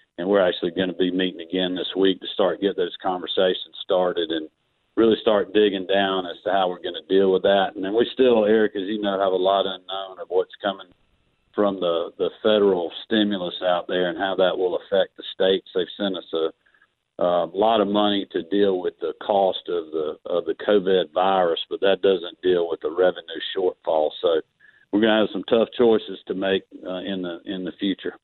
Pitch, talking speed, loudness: 100 Hz, 215 wpm, -22 LUFS